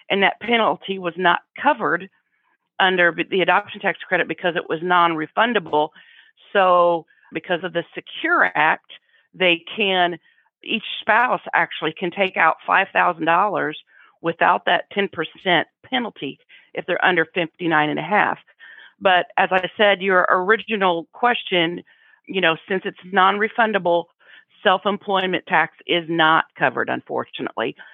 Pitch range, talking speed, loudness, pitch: 170-195 Hz, 135 wpm, -19 LUFS, 180 Hz